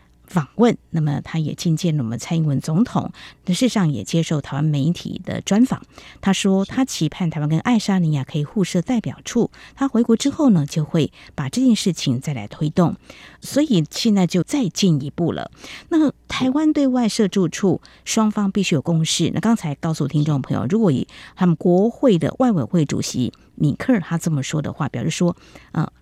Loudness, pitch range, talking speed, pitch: -20 LUFS, 155-220 Hz, 290 characters per minute, 175 Hz